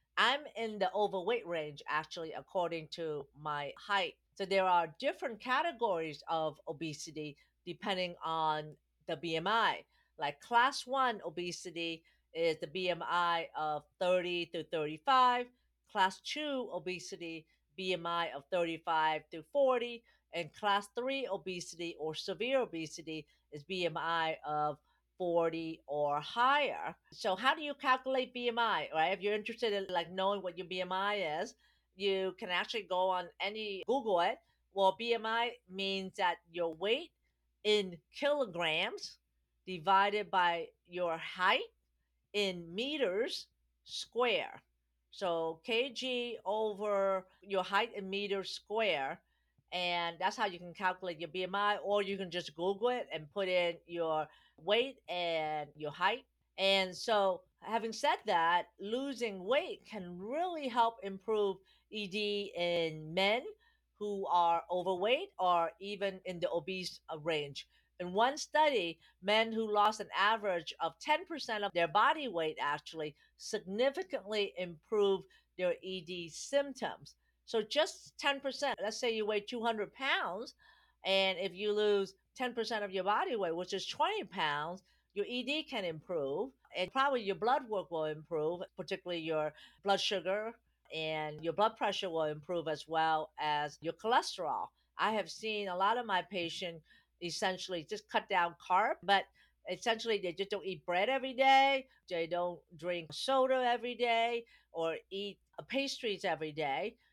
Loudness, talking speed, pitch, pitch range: -35 LUFS, 140 wpm, 190 Hz, 170-225 Hz